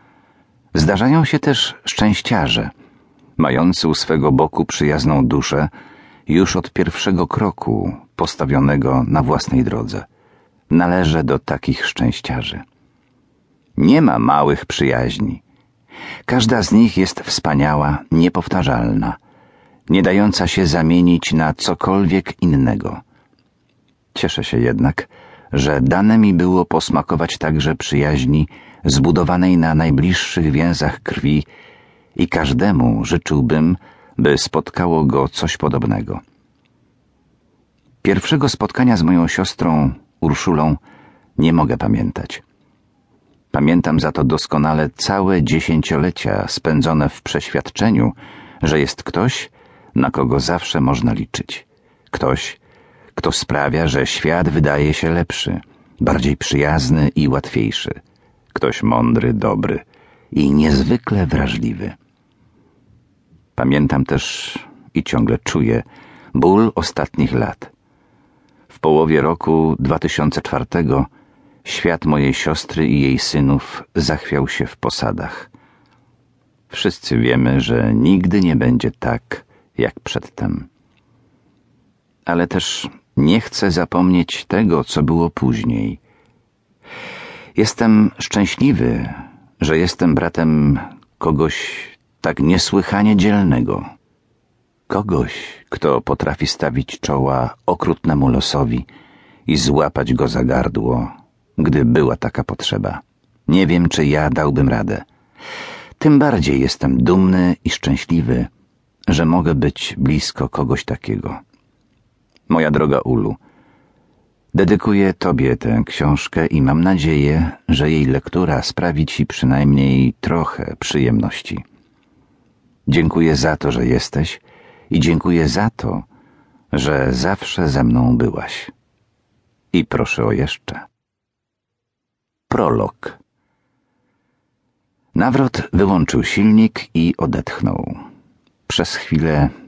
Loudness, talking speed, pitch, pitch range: -16 LUFS, 100 wpm, 80 Hz, 70-90 Hz